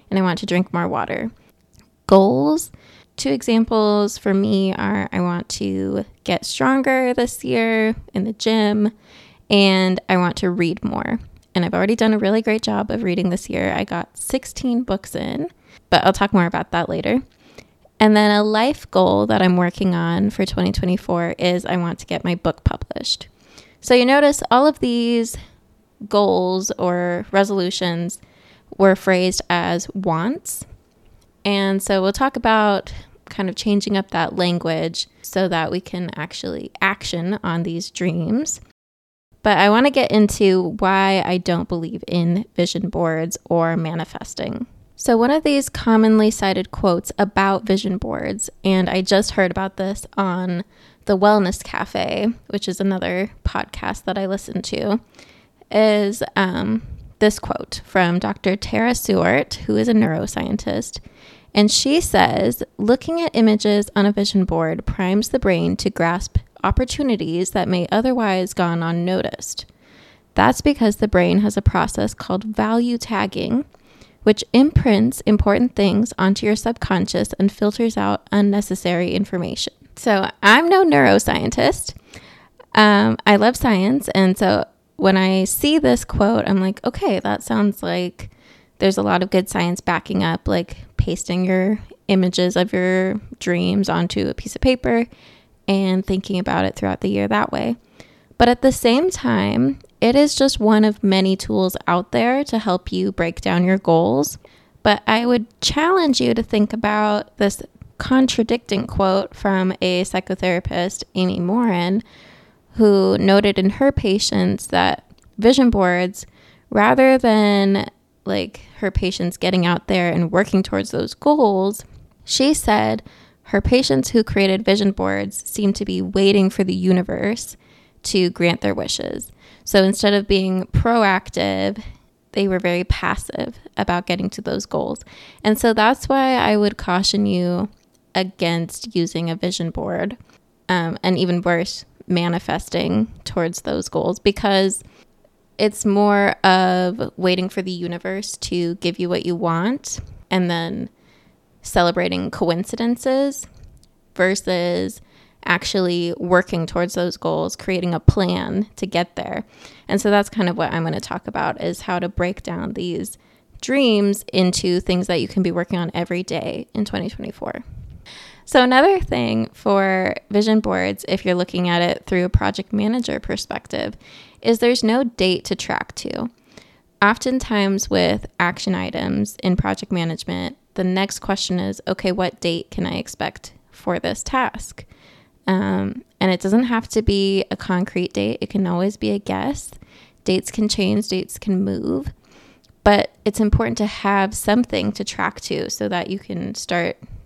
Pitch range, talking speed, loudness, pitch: 180-215 Hz, 155 wpm, -19 LUFS, 195 Hz